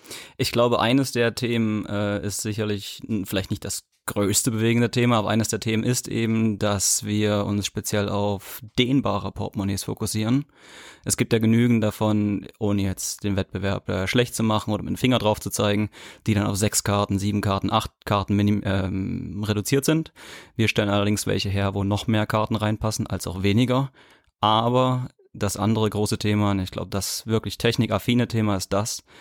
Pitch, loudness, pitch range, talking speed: 105 Hz, -23 LUFS, 100-115 Hz, 185 wpm